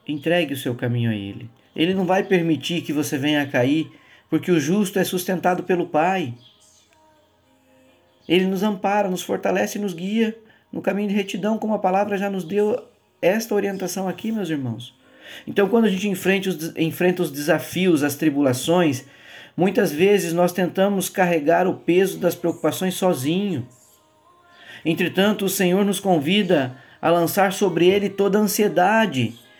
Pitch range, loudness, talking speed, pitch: 155-200 Hz, -21 LUFS, 155 wpm, 180 Hz